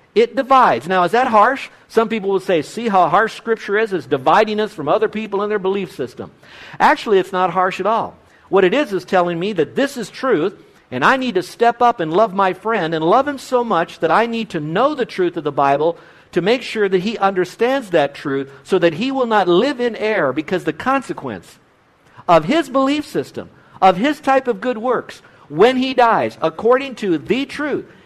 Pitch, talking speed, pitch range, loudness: 215 Hz, 220 wpm, 180-250 Hz, -17 LUFS